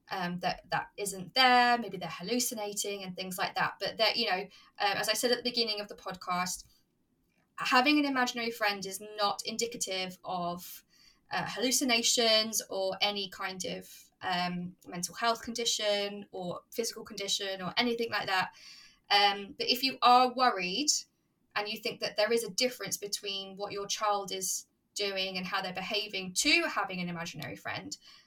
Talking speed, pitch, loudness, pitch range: 170 wpm, 205 Hz, -30 LUFS, 190-235 Hz